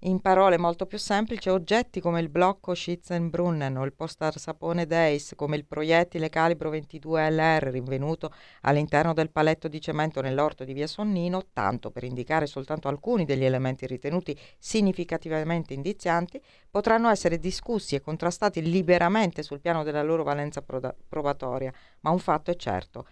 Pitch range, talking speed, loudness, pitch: 145-180 Hz, 150 wpm, -27 LUFS, 160 Hz